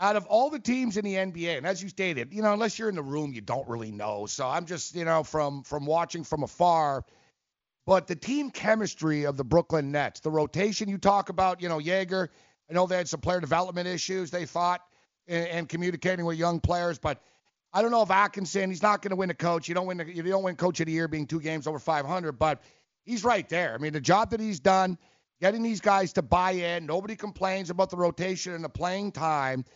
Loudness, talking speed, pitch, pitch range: -28 LUFS, 240 wpm, 175 Hz, 160-190 Hz